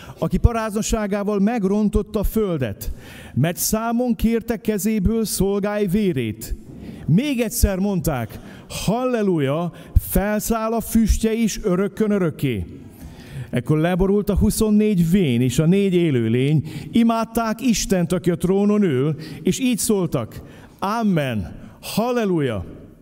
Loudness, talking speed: -20 LUFS, 105 wpm